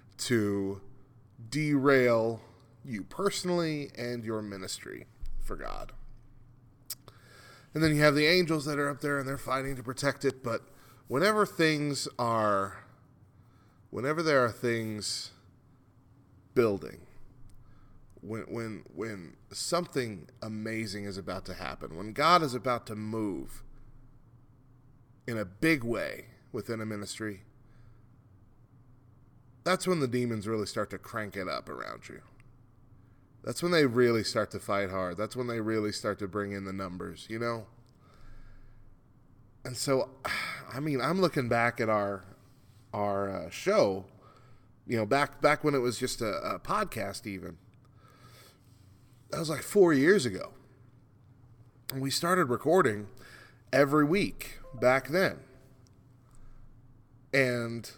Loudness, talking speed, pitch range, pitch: -30 LUFS, 130 wpm, 110-130 Hz, 120 Hz